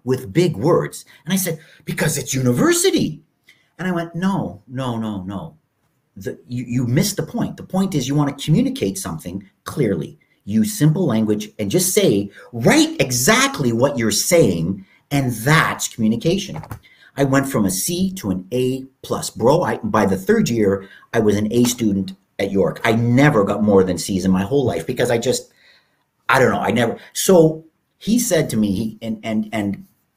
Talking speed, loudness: 185 wpm, -18 LUFS